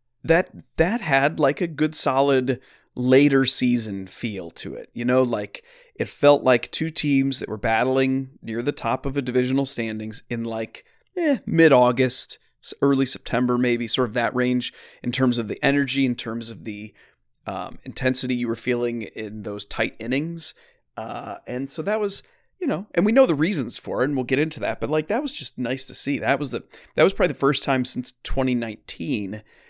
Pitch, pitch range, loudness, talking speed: 130 Hz, 120-145 Hz, -22 LUFS, 200 wpm